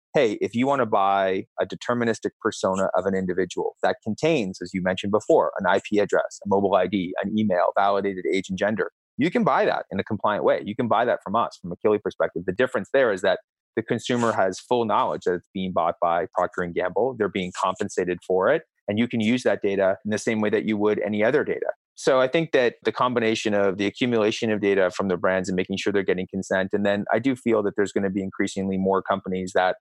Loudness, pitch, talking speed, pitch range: -24 LUFS, 100 Hz, 240 wpm, 95-110 Hz